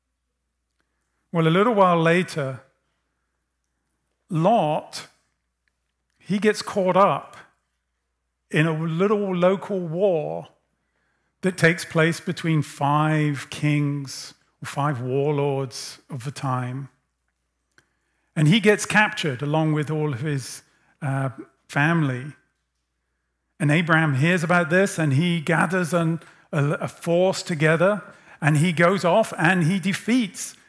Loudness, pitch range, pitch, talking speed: -22 LUFS, 125-175 Hz, 155 Hz, 115 wpm